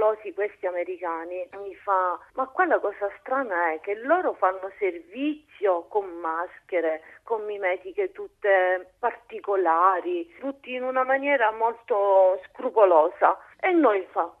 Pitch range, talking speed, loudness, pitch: 185-255 Hz, 115 wpm, -25 LUFS, 200 Hz